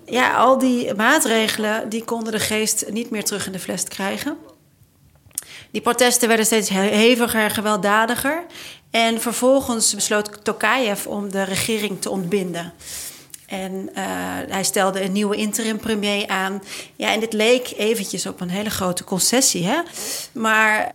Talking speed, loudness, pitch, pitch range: 150 wpm, -19 LUFS, 215 Hz, 195-230 Hz